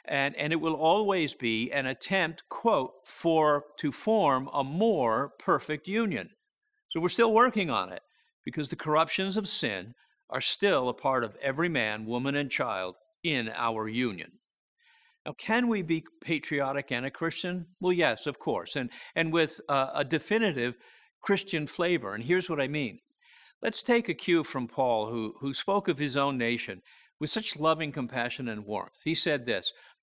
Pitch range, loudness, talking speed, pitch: 135-190 Hz, -29 LUFS, 175 wpm, 155 Hz